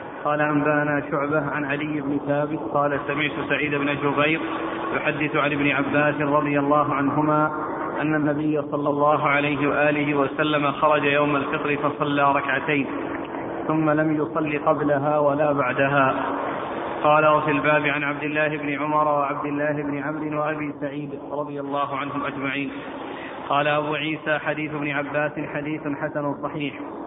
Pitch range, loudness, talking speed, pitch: 145-150 Hz, -23 LUFS, 140 wpm, 150 Hz